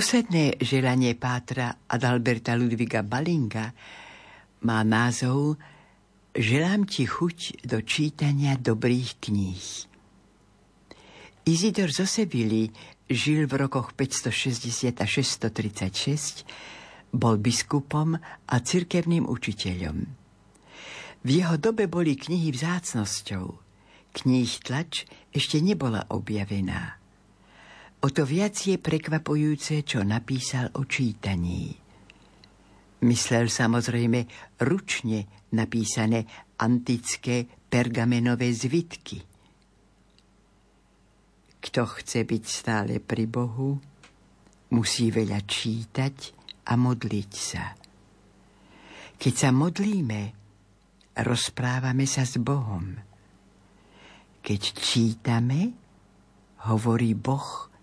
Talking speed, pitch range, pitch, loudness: 80 wpm, 110-140 Hz, 120 Hz, -26 LUFS